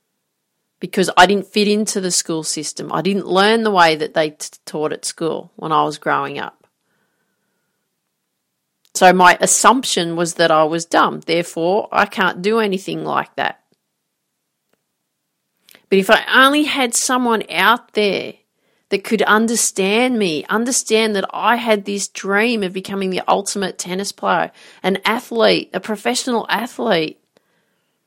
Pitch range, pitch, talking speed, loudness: 180-220 Hz, 200 Hz, 145 wpm, -16 LUFS